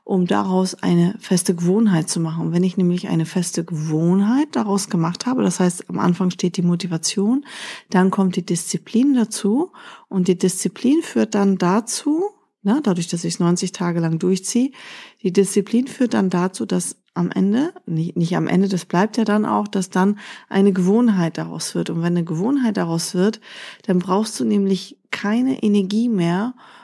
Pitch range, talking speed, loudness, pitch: 180-220 Hz, 180 wpm, -20 LUFS, 190 Hz